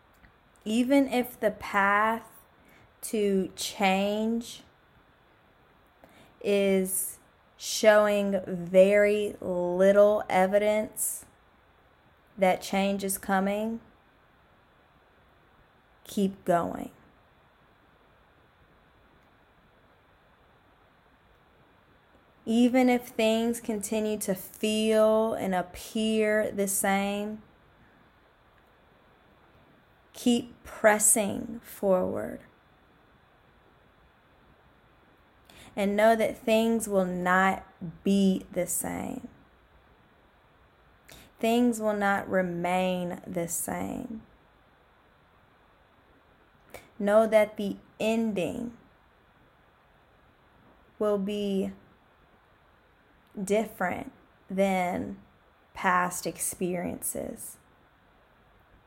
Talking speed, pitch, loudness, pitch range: 55 wpm, 205 Hz, -27 LUFS, 190-220 Hz